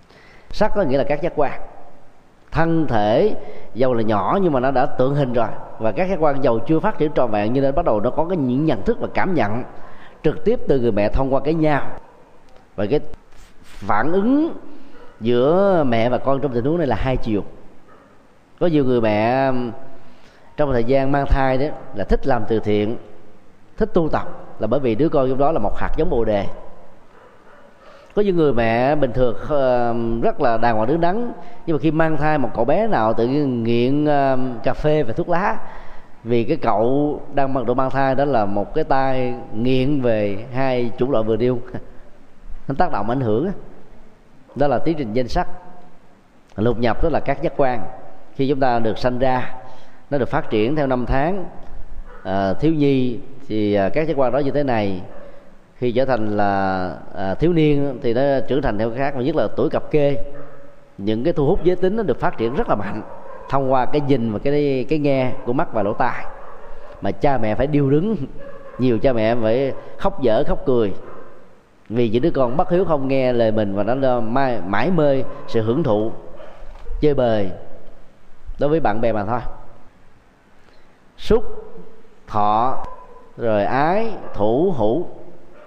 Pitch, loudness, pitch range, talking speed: 135 Hz, -20 LUFS, 115-150 Hz, 195 wpm